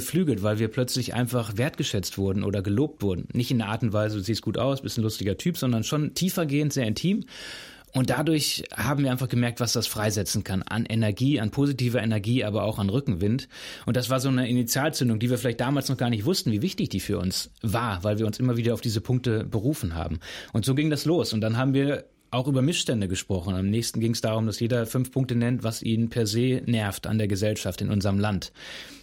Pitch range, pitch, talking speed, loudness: 105-130 Hz, 120 Hz, 230 wpm, -26 LUFS